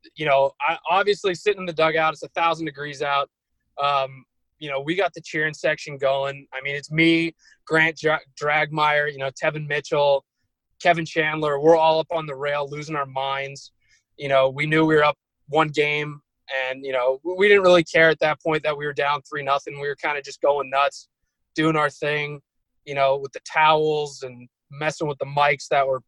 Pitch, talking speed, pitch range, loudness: 150 Hz, 210 wpm, 140-160 Hz, -22 LUFS